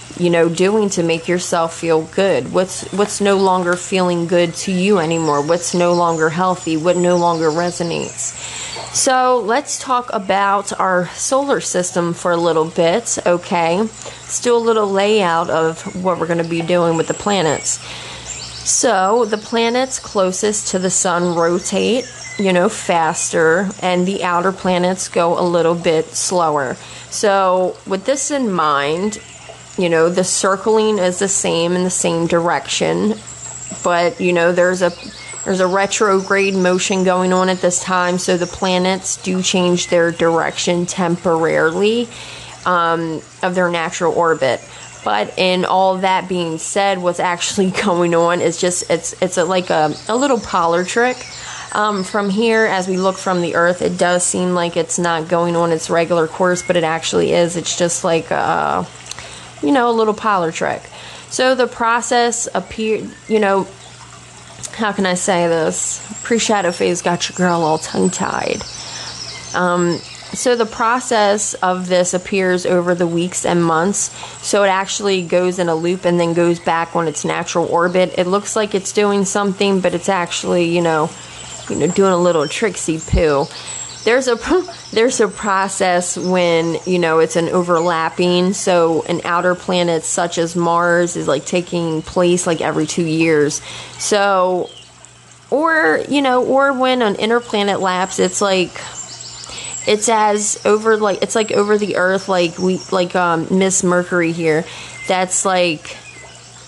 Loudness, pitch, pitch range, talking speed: -16 LUFS, 180 Hz, 170-200 Hz, 160 wpm